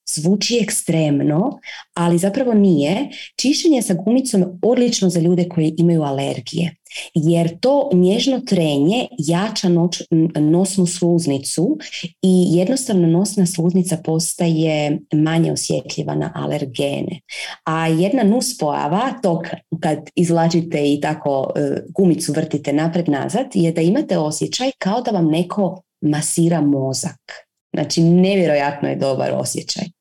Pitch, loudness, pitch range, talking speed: 170 Hz, -18 LUFS, 160-190 Hz, 115 wpm